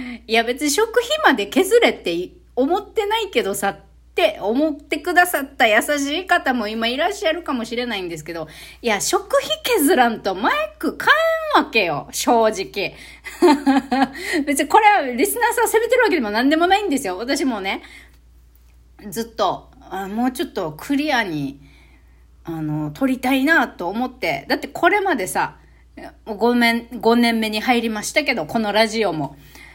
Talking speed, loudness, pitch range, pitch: 315 characters per minute, -19 LUFS, 215-335 Hz, 265 Hz